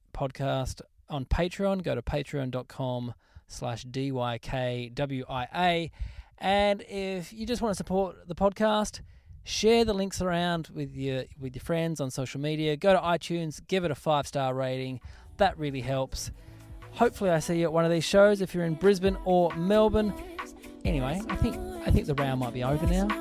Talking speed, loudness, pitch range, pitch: 175 wpm, -28 LUFS, 130-195 Hz, 160 Hz